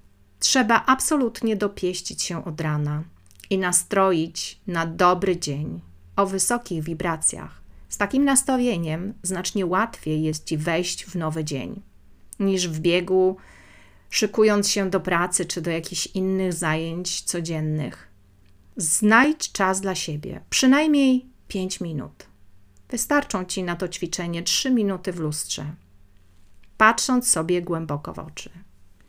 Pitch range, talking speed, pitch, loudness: 150-200 Hz, 120 wpm, 175 Hz, -23 LUFS